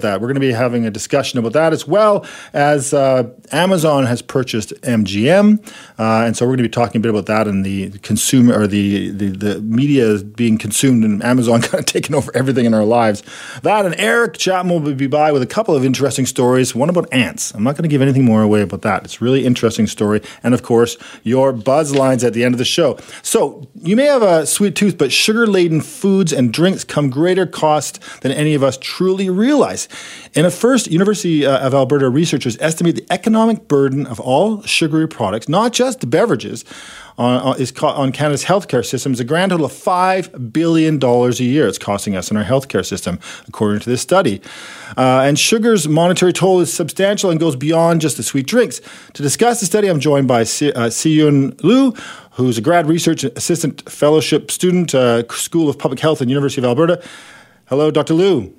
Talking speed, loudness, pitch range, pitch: 210 wpm, -15 LUFS, 120-170 Hz, 140 Hz